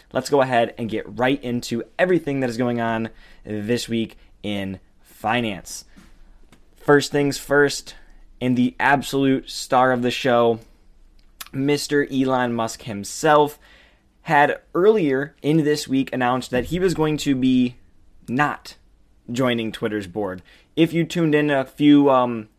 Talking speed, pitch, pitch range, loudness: 140 wpm, 130 Hz, 115-145 Hz, -21 LUFS